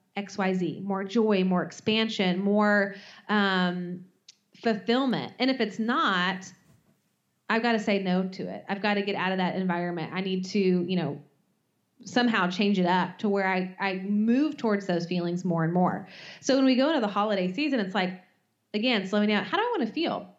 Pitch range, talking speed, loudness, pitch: 185-220 Hz, 195 wpm, -27 LUFS, 195 Hz